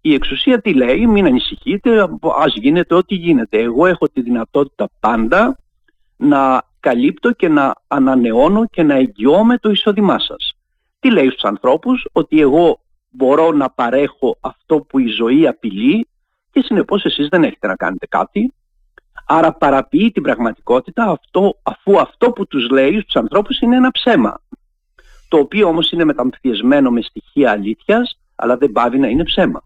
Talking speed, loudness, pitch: 155 wpm, -14 LUFS, 205 Hz